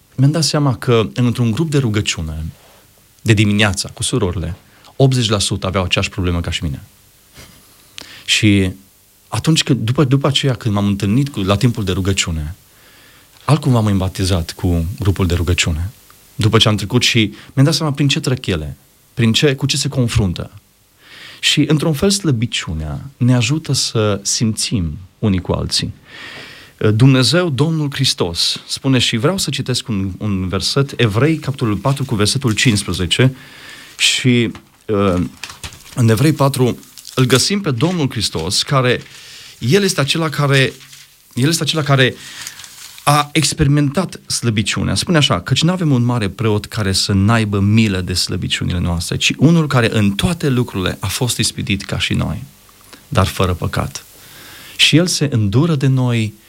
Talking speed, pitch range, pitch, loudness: 150 wpm, 100-140 Hz, 115 Hz, -16 LUFS